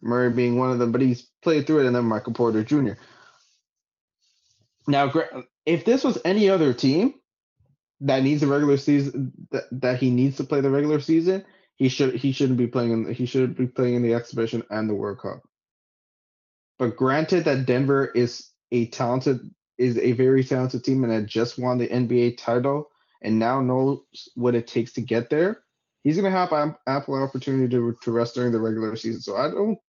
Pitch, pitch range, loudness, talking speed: 130 Hz, 120-140 Hz, -23 LUFS, 195 wpm